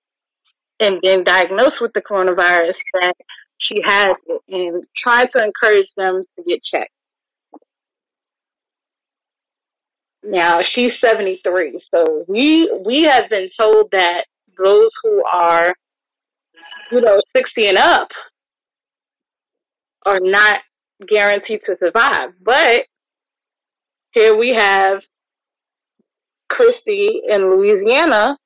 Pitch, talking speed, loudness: 215 Hz, 100 wpm, -14 LUFS